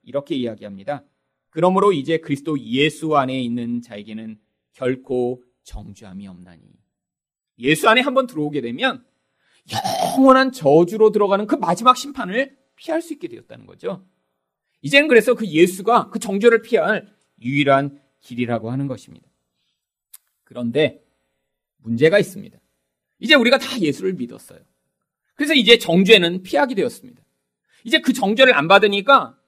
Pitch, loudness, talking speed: 170 Hz, -17 LUFS, 320 characters per minute